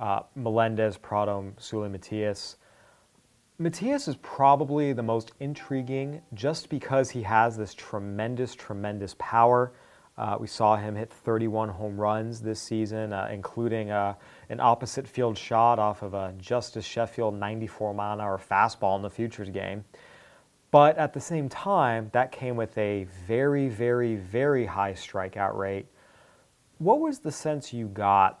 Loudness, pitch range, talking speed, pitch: -27 LUFS, 105-125 Hz, 150 wpm, 110 Hz